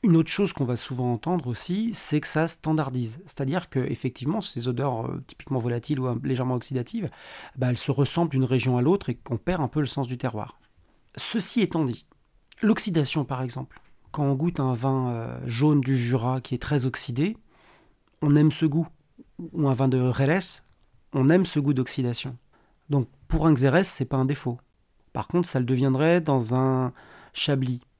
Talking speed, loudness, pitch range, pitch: 195 wpm, -26 LUFS, 125-155 Hz, 135 Hz